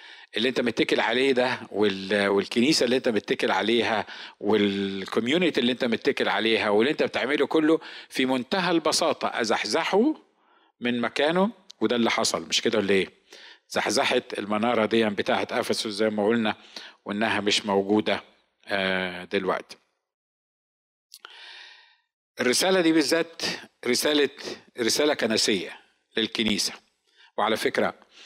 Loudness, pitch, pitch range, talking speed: -24 LUFS, 110 Hz, 100-140 Hz, 115 wpm